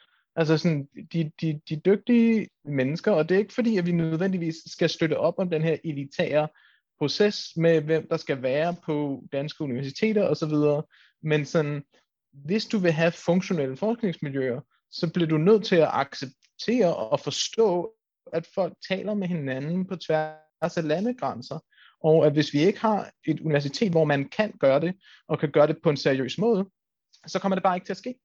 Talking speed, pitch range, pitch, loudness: 185 wpm, 150-195 Hz, 165 Hz, -25 LUFS